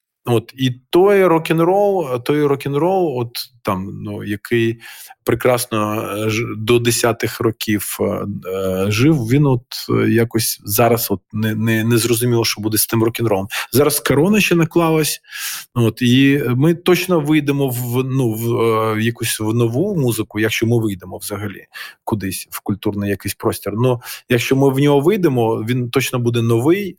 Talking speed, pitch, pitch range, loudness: 155 wpm, 120 Hz, 110-140 Hz, -17 LUFS